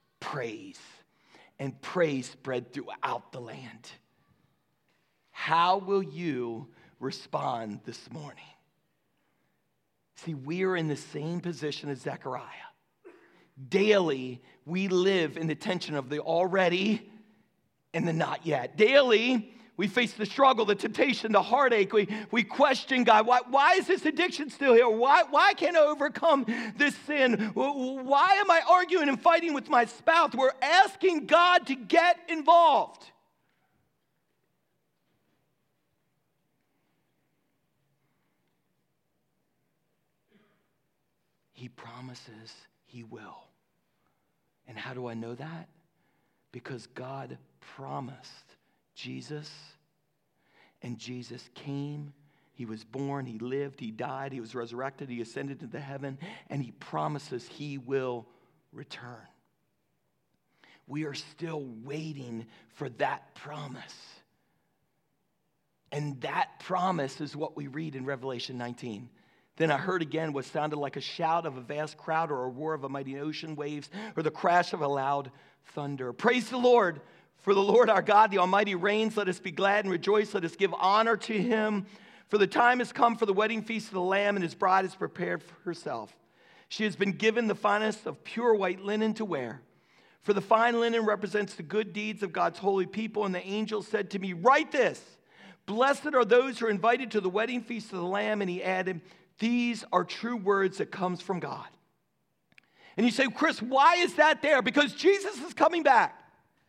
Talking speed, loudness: 150 wpm, -27 LUFS